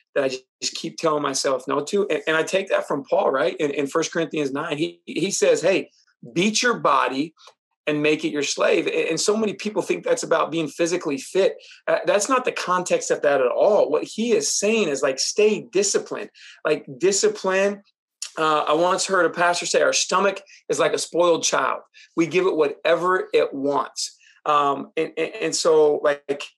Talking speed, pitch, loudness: 200 wpm, 195 Hz, -21 LUFS